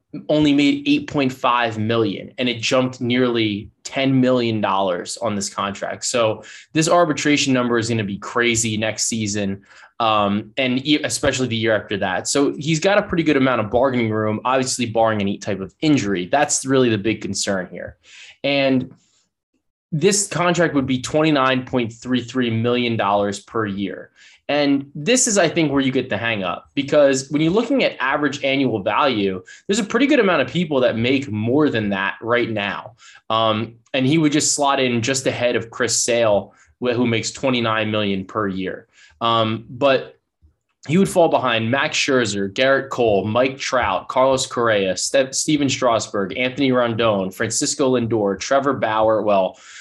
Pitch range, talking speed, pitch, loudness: 110-140 Hz, 165 wpm, 125 Hz, -19 LUFS